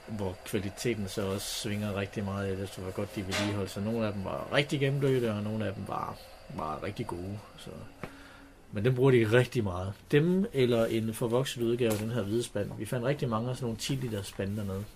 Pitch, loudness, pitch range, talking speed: 110 Hz, -31 LUFS, 100-125 Hz, 225 wpm